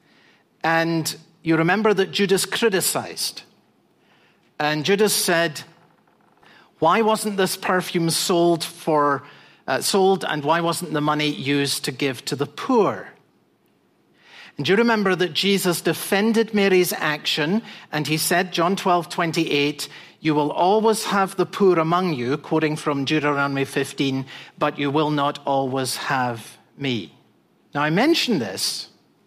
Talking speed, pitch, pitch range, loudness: 130 wpm, 165 Hz, 145-190 Hz, -21 LUFS